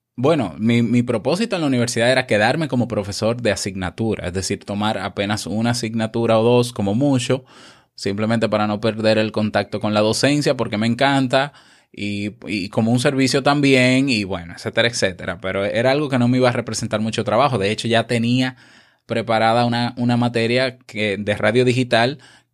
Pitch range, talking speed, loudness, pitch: 105-125 Hz, 180 wpm, -19 LUFS, 115 Hz